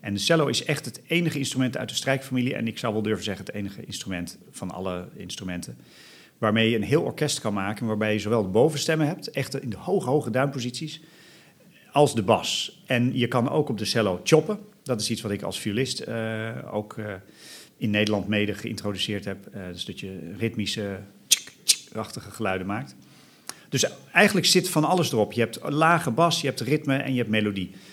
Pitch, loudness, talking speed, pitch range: 115 Hz, -25 LUFS, 205 wpm, 105-145 Hz